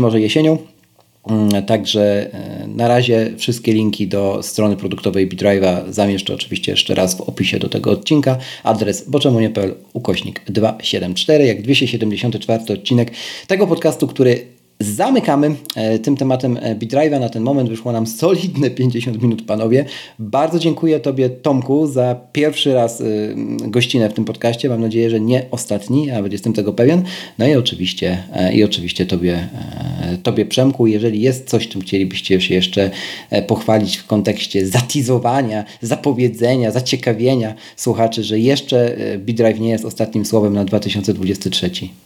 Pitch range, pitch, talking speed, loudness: 105-130 Hz, 115 Hz, 135 wpm, -16 LUFS